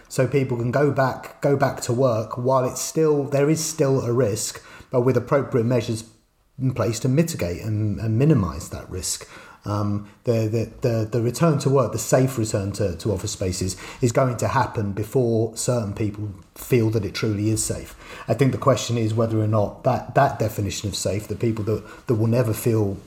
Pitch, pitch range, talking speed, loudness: 115 Hz, 105-130 Hz, 205 wpm, -22 LUFS